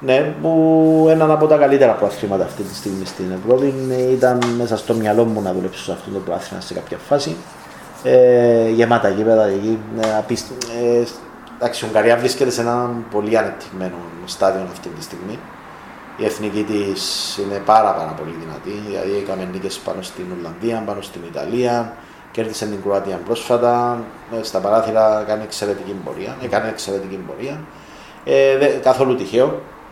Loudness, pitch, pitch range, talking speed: -18 LUFS, 110 Hz, 100-120 Hz, 150 wpm